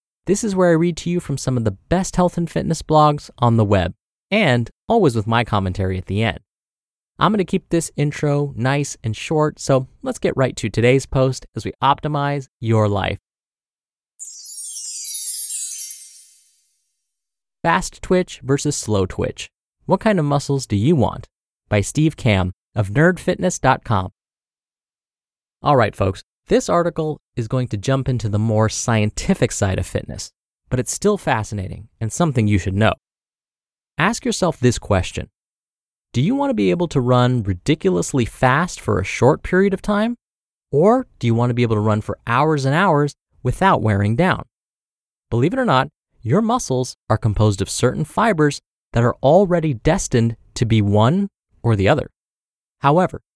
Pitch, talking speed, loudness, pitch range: 130 Hz, 165 wpm, -19 LUFS, 110-165 Hz